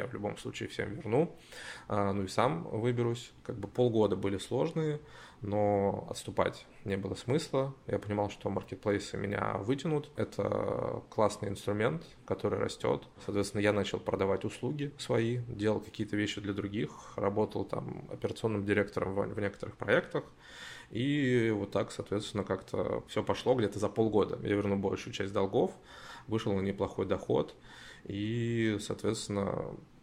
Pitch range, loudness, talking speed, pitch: 100-115 Hz, -33 LUFS, 140 wpm, 105 Hz